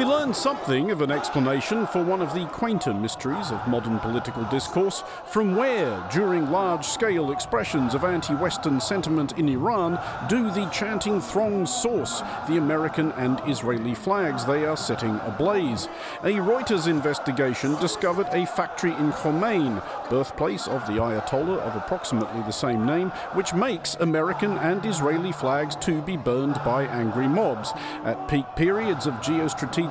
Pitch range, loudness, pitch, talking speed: 135-190 Hz, -25 LUFS, 155 Hz, 155 wpm